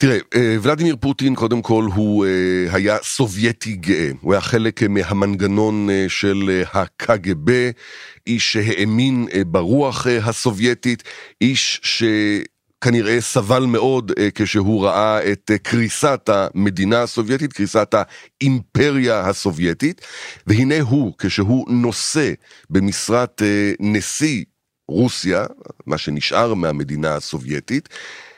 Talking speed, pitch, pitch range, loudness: 90 wpm, 110 Hz, 100-120 Hz, -18 LUFS